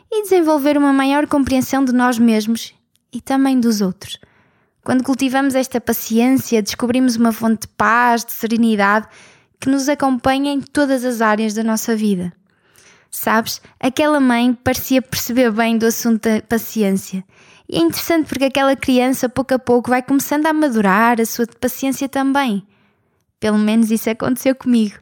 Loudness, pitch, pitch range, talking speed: -16 LUFS, 250 Hz, 225-270 Hz, 155 wpm